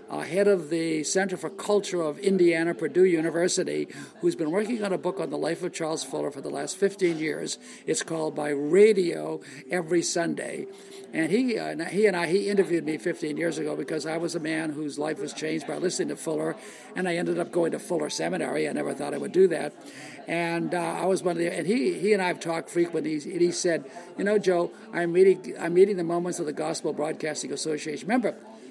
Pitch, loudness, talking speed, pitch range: 170 Hz, -26 LUFS, 225 wpm, 160-190 Hz